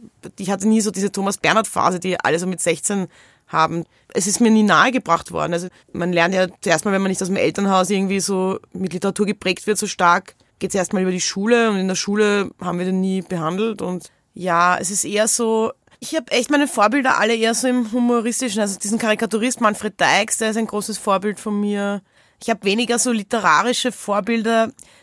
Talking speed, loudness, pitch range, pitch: 215 wpm, -19 LUFS, 185-225 Hz, 205 Hz